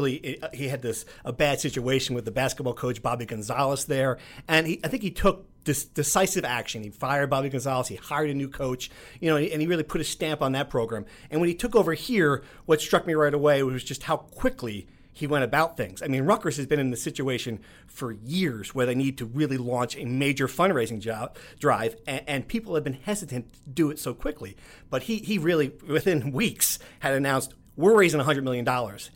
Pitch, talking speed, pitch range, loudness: 140 Hz, 220 wpm, 125-155 Hz, -26 LUFS